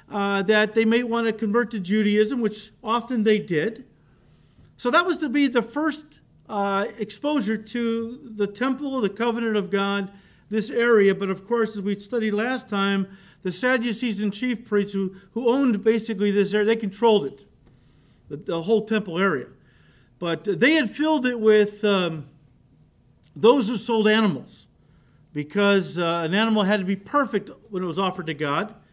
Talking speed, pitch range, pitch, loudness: 170 wpm, 195-235 Hz, 215 Hz, -23 LUFS